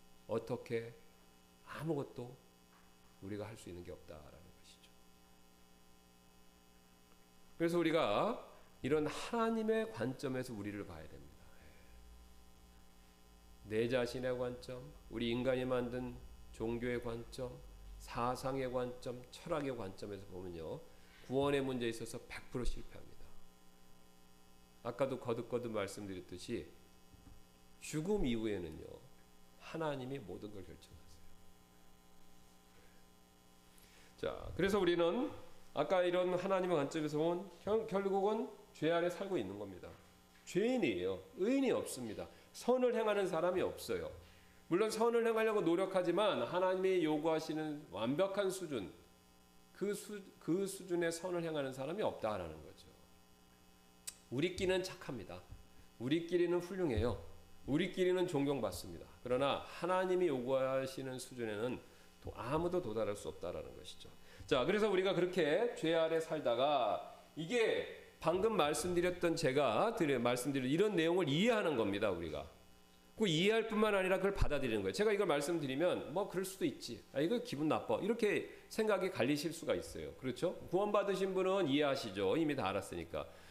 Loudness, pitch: -37 LUFS, 125 Hz